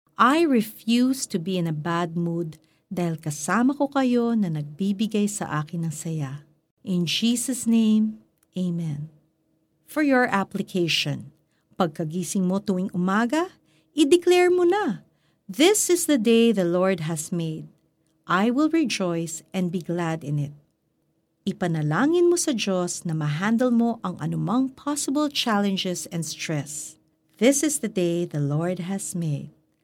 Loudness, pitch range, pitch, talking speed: -24 LUFS, 160-235 Hz, 185 Hz, 140 wpm